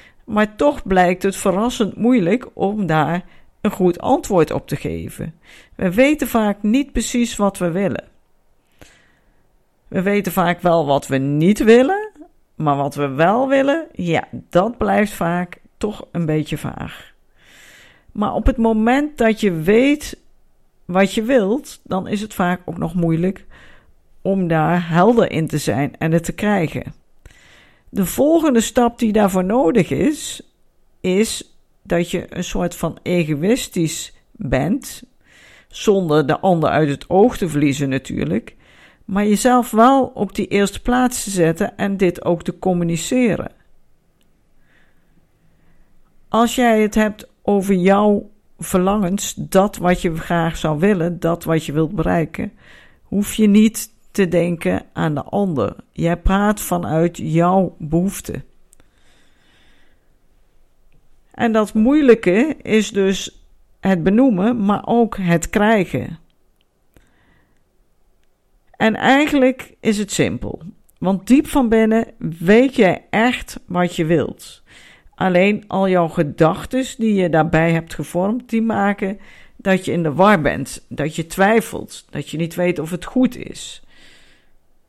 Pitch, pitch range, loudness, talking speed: 195 Hz, 170-225 Hz, -18 LUFS, 135 wpm